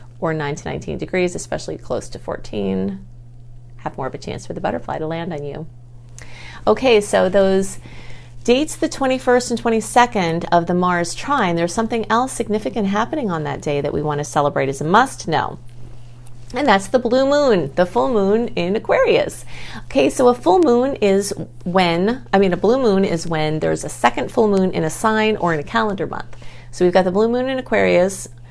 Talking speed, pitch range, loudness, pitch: 200 wpm, 140-225 Hz, -18 LUFS, 180 Hz